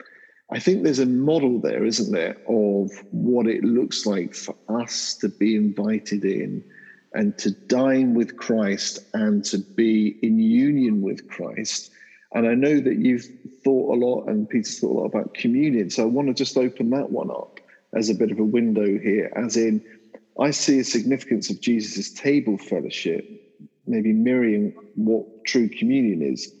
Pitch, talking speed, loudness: 125 Hz, 175 wpm, -22 LUFS